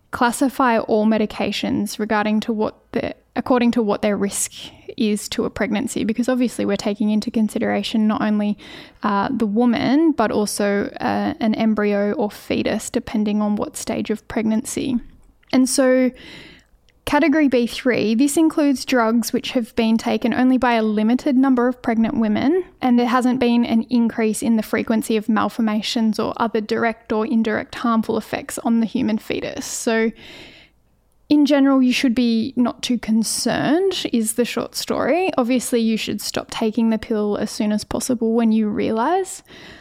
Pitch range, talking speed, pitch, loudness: 220-255 Hz, 165 wpm, 230 Hz, -19 LUFS